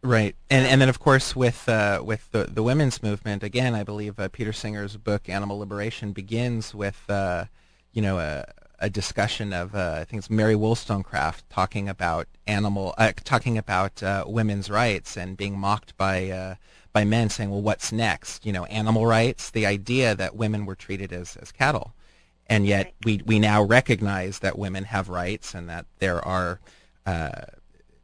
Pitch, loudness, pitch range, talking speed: 105 Hz, -25 LUFS, 95-110 Hz, 180 wpm